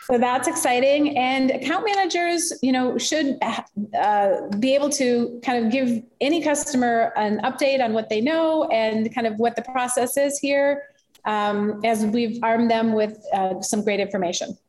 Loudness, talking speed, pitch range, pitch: -22 LUFS, 170 wpm, 225-280 Hz, 245 Hz